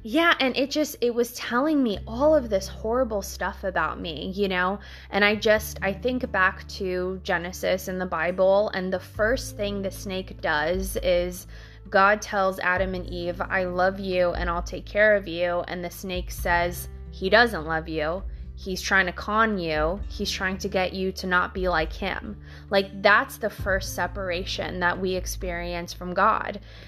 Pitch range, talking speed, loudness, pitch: 175-205 Hz, 185 wpm, -25 LUFS, 190 Hz